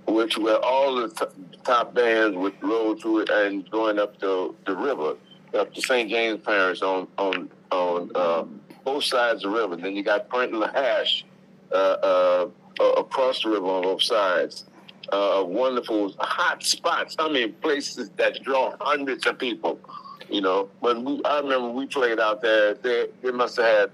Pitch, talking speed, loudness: 115 Hz, 180 wpm, -24 LUFS